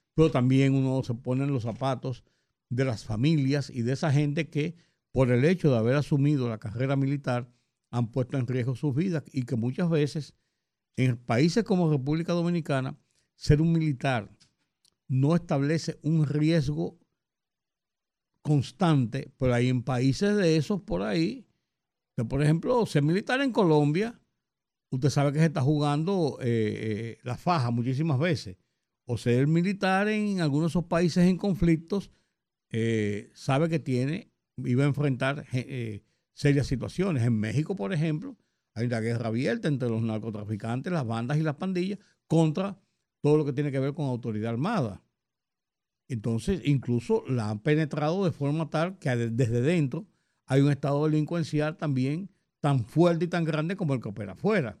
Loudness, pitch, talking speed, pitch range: -27 LUFS, 145 Hz, 160 wpm, 125-165 Hz